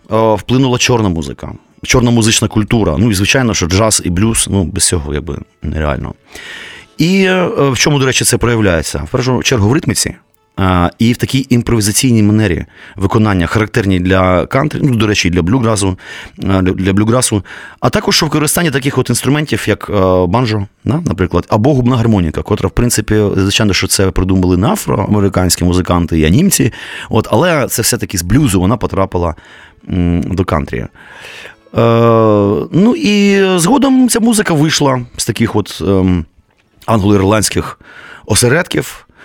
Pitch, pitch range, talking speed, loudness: 110 Hz, 95-125 Hz, 150 wpm, -12 LUFS